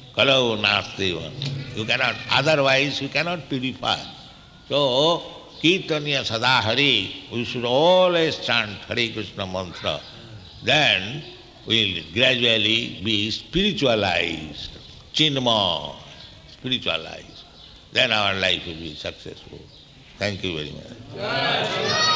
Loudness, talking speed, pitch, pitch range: -21 LUFS, 90 wpm, 115 Hz, 95-135 Hz